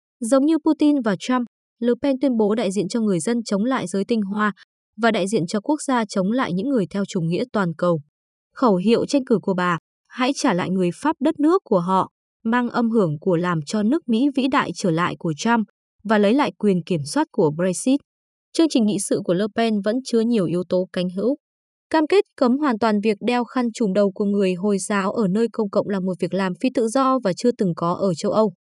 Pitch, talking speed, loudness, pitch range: 220 Hz, 245 wpm, -21 LUFS, 190-255 Hz